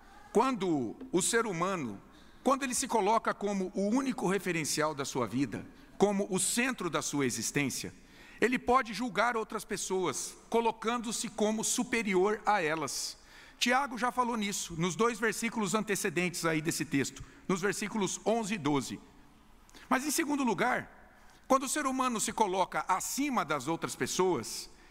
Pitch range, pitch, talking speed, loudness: 175-235 Hz, 205 Hz, 145 wpm, -31 LUFS